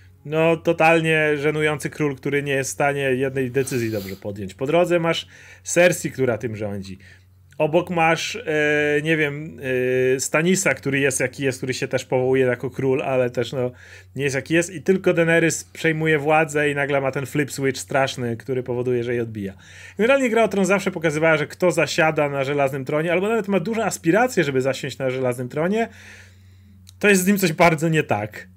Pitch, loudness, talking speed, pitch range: 140 Hz, -21 LUFS, 190 wpm, 125-165 Hz